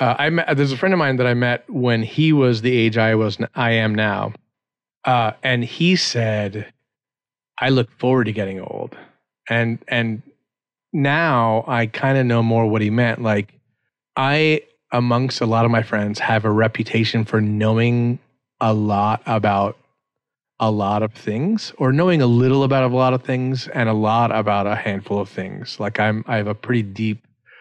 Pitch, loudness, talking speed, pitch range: 115 Hz, -19 LUFS, 185 wpm, 110-130 Hz